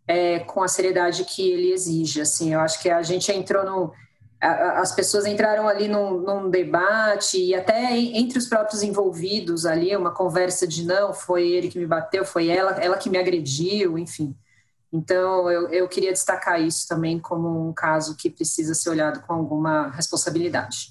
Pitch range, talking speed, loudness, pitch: 165-195 Hz, 180 wpm, -22 LUFS, 180 Hz